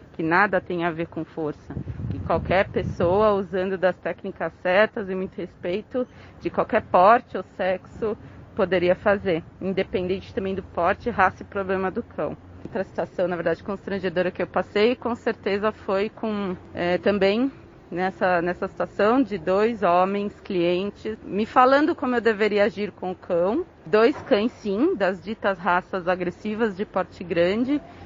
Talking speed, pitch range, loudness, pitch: 155 wpm, 180-215 Hz, -24 LUFS, 195 Hz